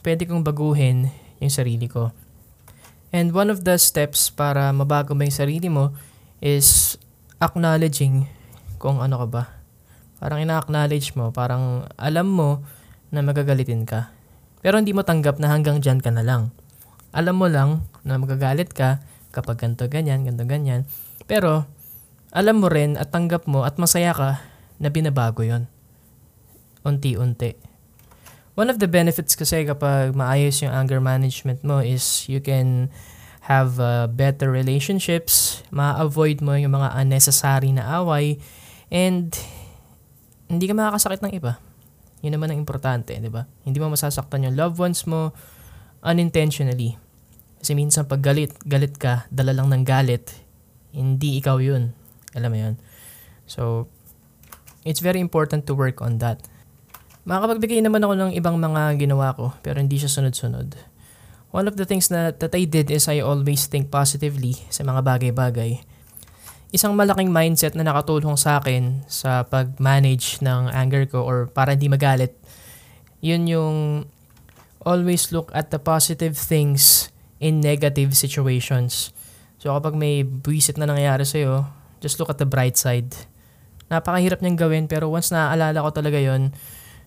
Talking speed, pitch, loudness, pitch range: 145 wpm, 140 Hz, -20 LUFS, 125-155 Hz